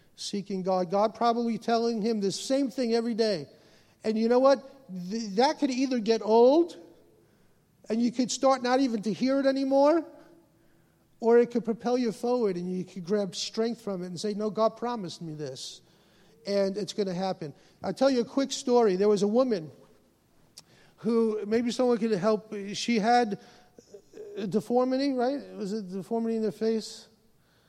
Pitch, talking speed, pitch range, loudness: 225 Hz, 180 wpm, 205-245 Hz, -27 LUFS